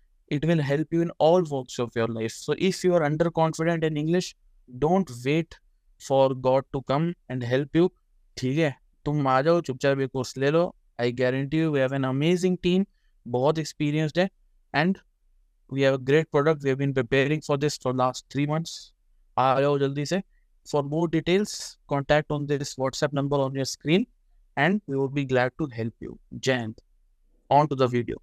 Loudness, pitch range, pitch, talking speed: -25 LUFS, 130-160 Hz, 145 Hz, 195 wpm